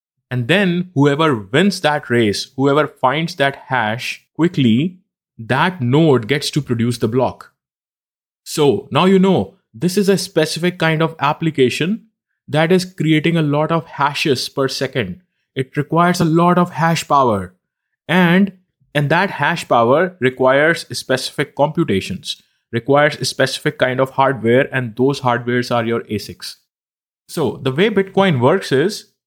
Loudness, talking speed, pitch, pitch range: -16 LUFS, 145 wpm, 145 Hz, 130-170 Hz